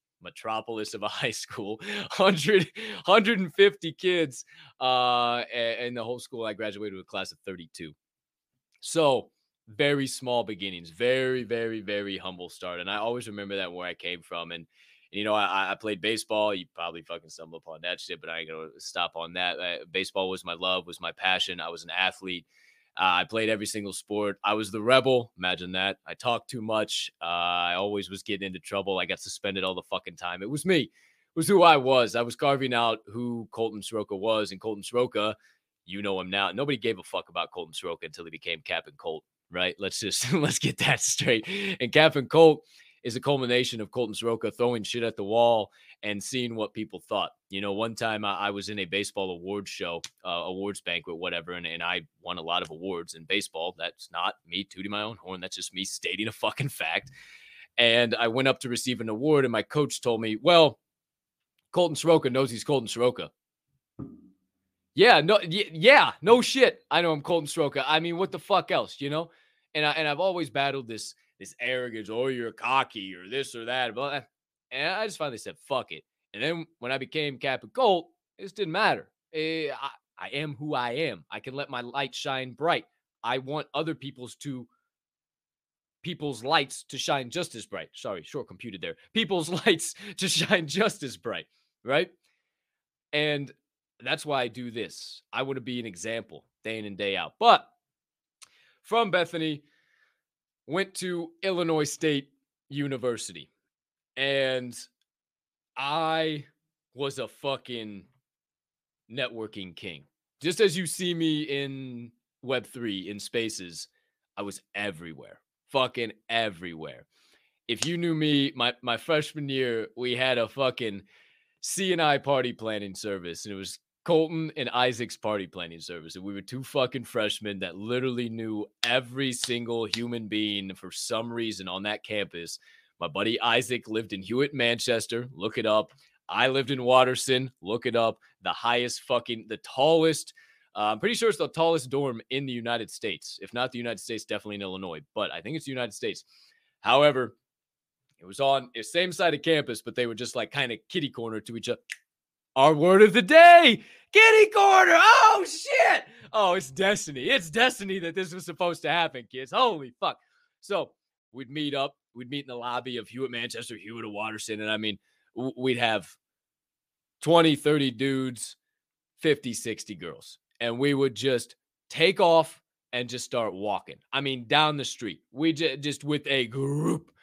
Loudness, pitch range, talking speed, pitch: -26 LUFS, 105-150 Hz, 180 wpm, 125 Hz